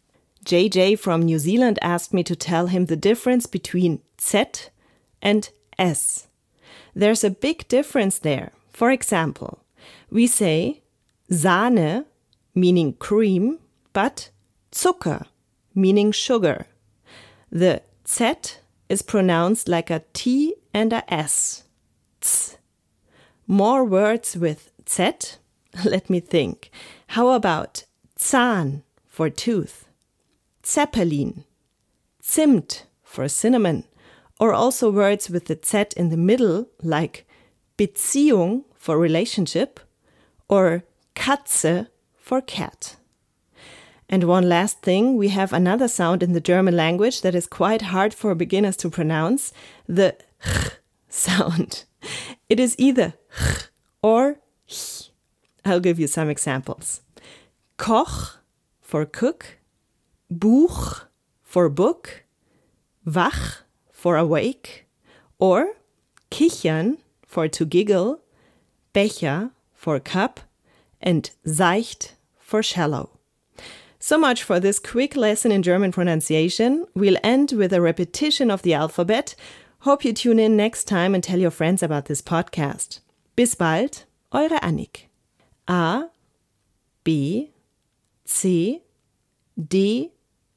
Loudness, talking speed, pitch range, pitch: -21 LUFS, 110 wpm, 170-235 Hz, 190 Hz